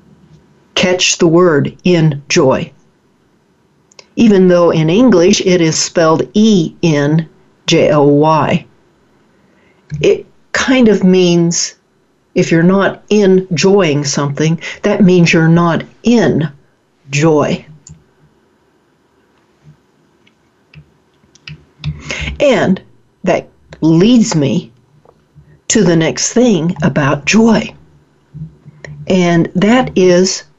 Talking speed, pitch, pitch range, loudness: 90 wpm, 175 Hz, 155-190 Hz, -11 LUFS